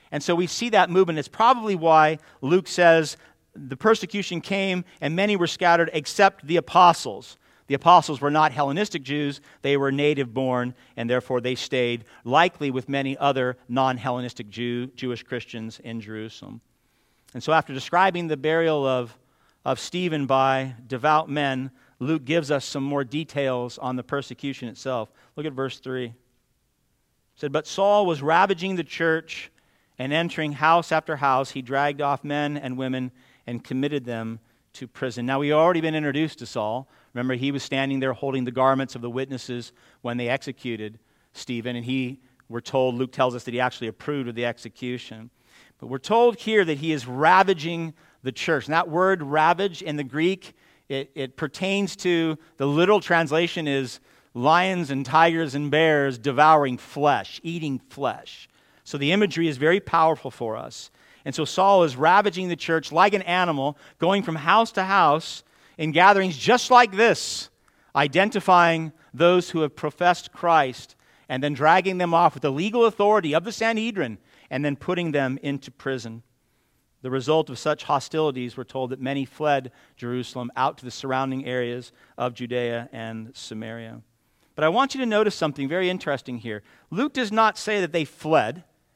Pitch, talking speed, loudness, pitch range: 145 Hz, 170 wpm, -23 LUFS, 130-170 Hz